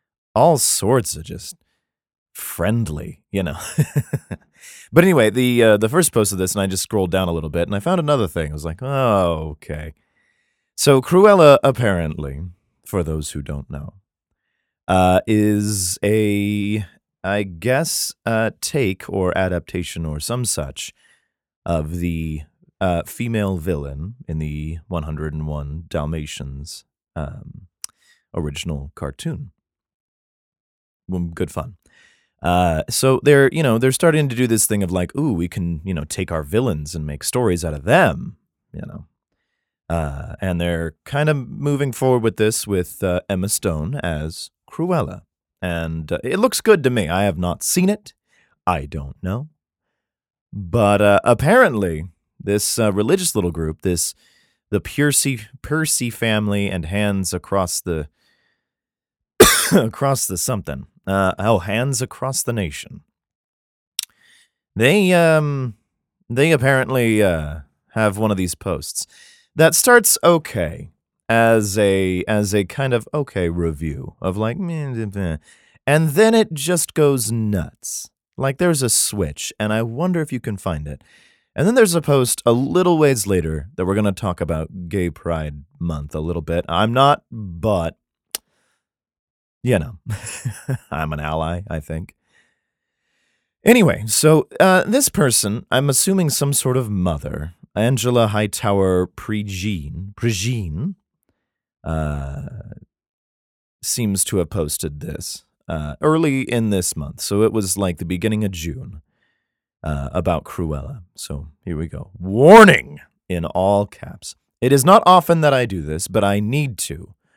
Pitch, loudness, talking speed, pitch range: 100 Hz, -18 LUFS, 145 wpm, 85-125 Hz